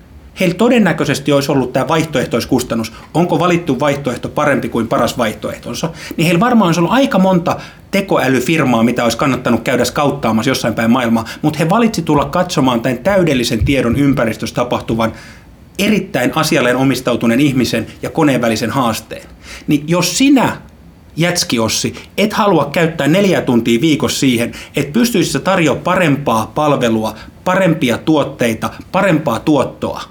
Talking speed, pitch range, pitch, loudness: 135 wpm, 120-170 Hz, 140 Hz, -14 LUFS